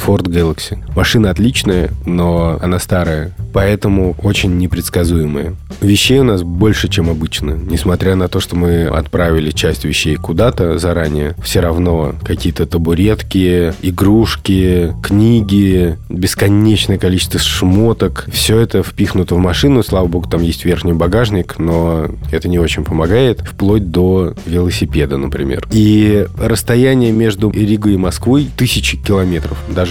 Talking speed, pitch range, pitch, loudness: 130 wpm, 85-100 Hz, 90 Hz, -13 LUFS